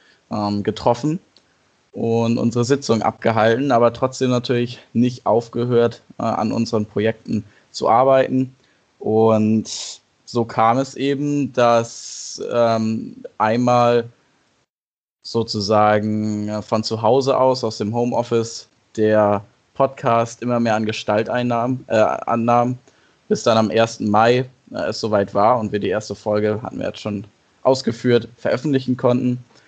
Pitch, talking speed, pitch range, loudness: 115 Hz, 120 wpm, 110-125 Hz, -19 LUFS